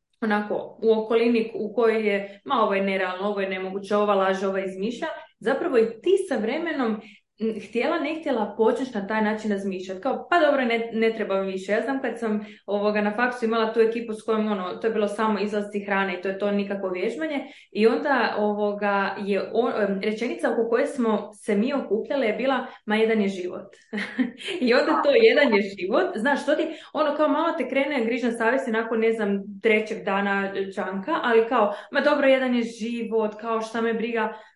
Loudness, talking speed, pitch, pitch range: -24 LUFS, 195 wpm, 220 Hz, 205-250 Hz